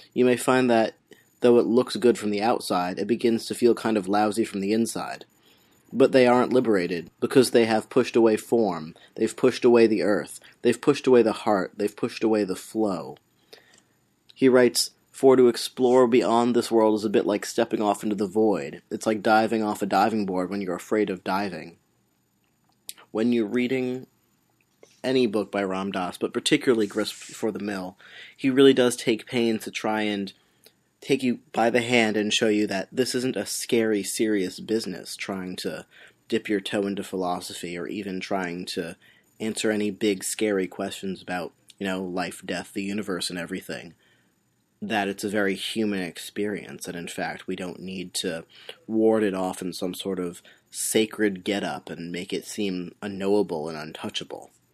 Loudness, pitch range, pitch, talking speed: -24 LUFS, 95-115 Hz, 105 Hz, 180 wpm